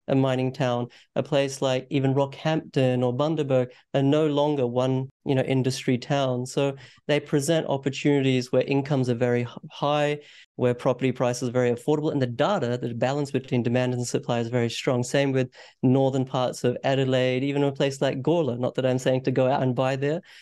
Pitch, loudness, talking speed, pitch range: 130 Hz, -25 LUFS, 195 wpm, 125-140 Hz